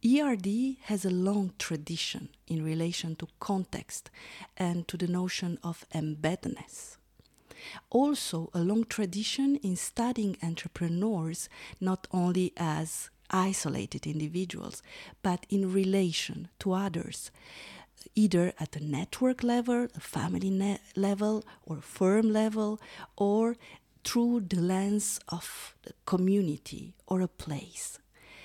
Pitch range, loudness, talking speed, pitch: 170-210 Hz, -31 LUFS, 110 wpm, 185 Hz